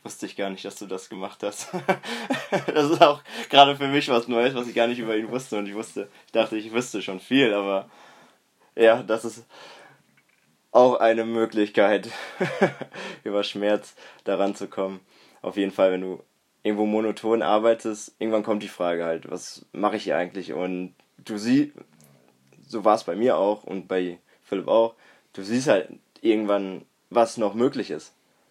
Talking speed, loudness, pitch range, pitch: 175 wpm, -24 LUFS, 100-115 Hz, 110 Hz